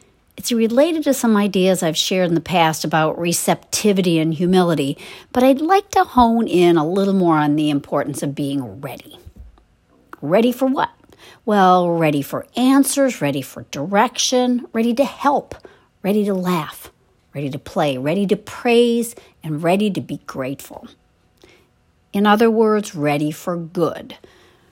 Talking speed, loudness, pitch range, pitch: 150 wpm, -18 LUFS, 155-235 Hz, 185 Hz